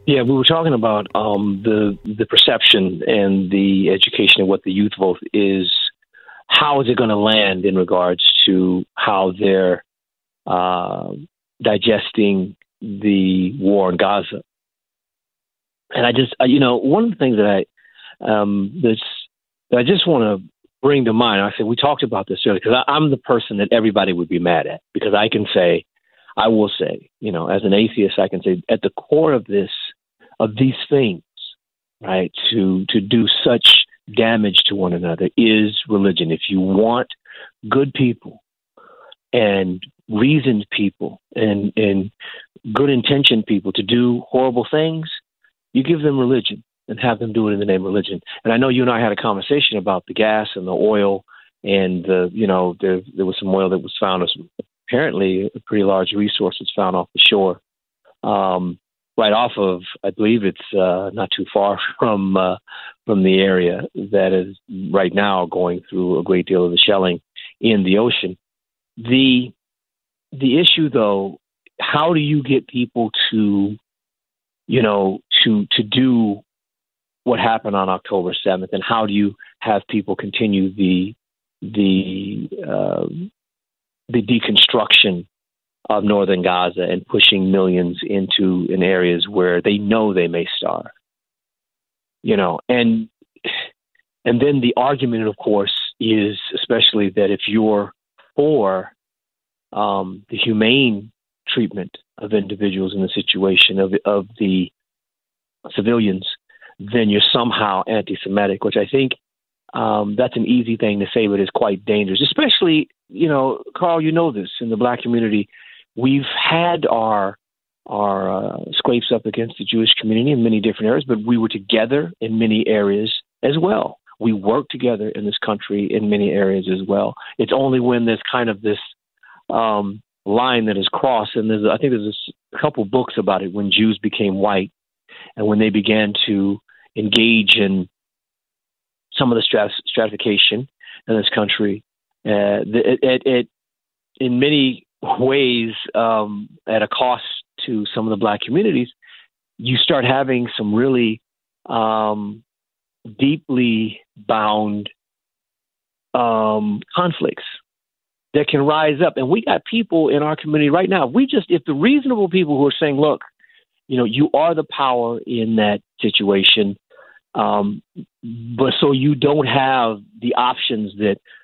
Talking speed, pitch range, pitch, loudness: 160 wpm, 100-125 Hz, 105 Hz, -17 LUFS